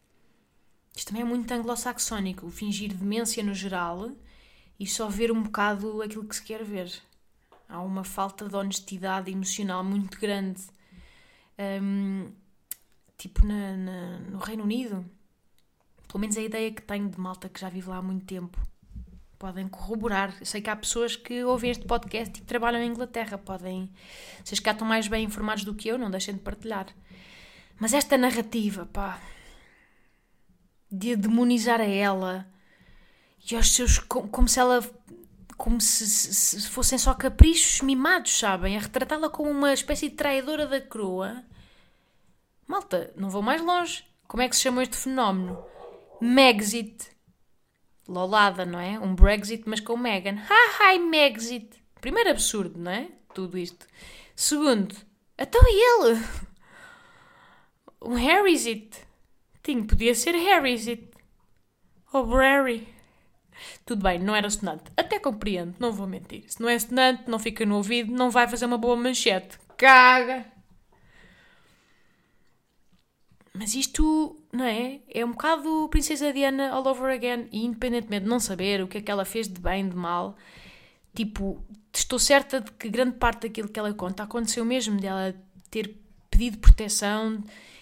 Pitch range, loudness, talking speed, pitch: 200-250 Hz, -25 LUFS, 150 wpm, 225 Hz